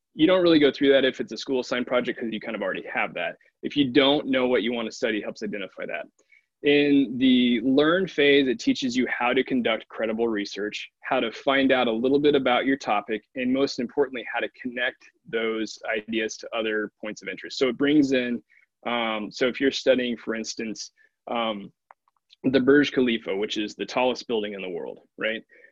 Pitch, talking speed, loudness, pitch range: 130 Hz, 210 wpm, -24 LUFS, 115-145 Hz